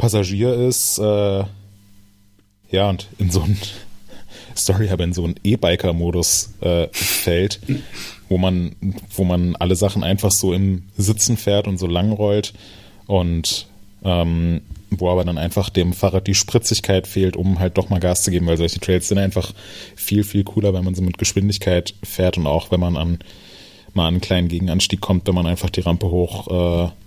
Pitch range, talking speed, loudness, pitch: 90-100 Hz, 180 wpm, -19 LUFS, 95 Hz